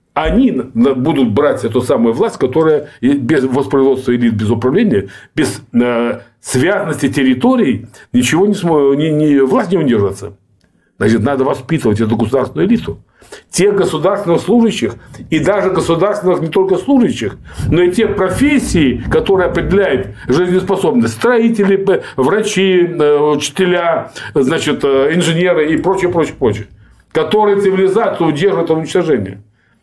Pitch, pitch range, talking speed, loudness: 160 Hz, 130-195 Hz, 120 wpm, -13 LUFS